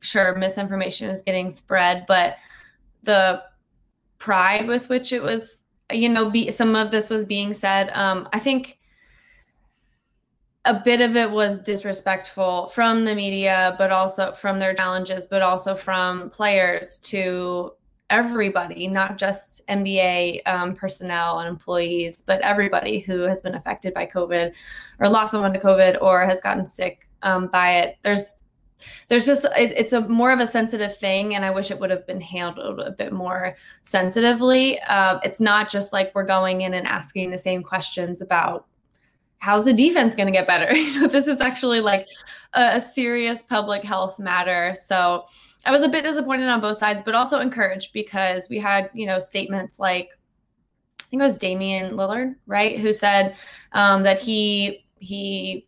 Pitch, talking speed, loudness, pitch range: 195 Hz, 170 wpm, -21 LUFS, 185-220 Hz